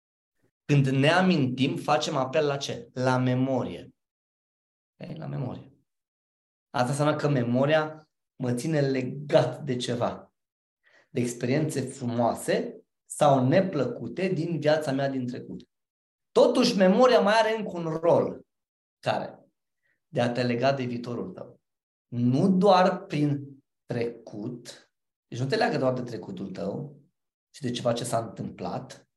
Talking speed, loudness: 130 wpm, -26 LUFS